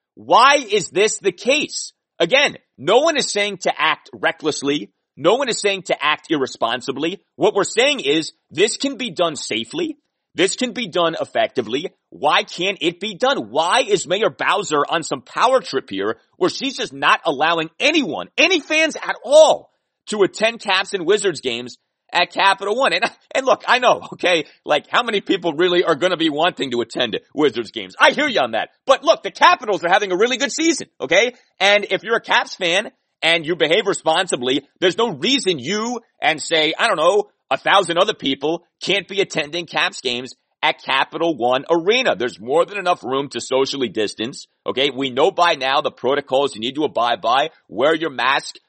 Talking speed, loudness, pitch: 195 wpm, -18 LUFS, 195 Hz